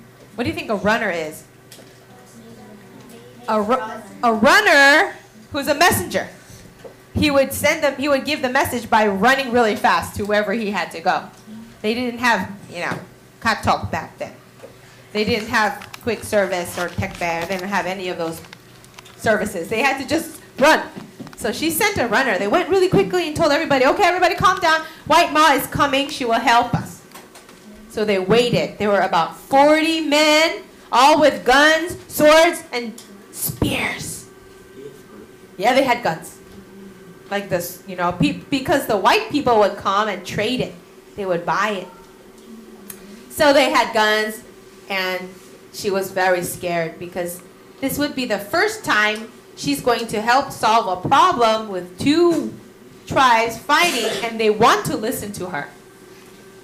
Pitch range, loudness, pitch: 195-285 Hz, -18 LUFS, 225 Hz